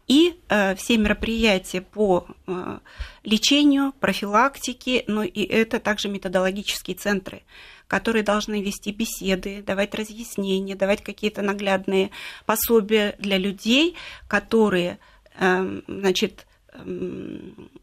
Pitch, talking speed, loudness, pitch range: 205 Hz, 90 wpm, -23 LUFS, 195-225 Hz